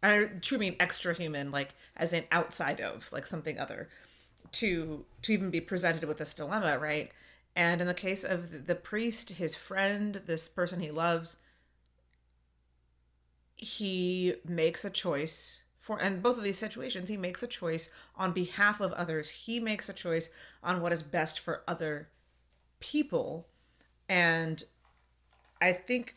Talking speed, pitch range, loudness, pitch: 155 wpm, 150-195 Hz, -31 LUFS, 175 Hz